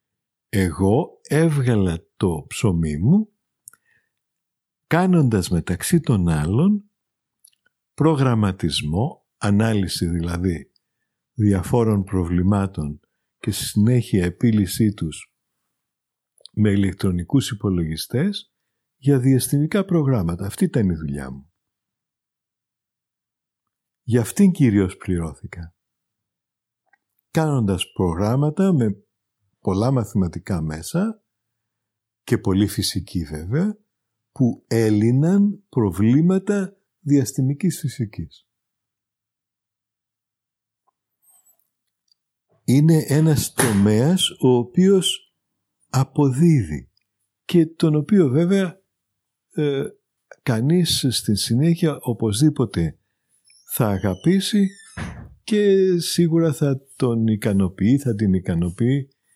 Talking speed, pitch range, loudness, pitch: 75 wpm, 100-155 Hz, -20 LUFS, 115 Hz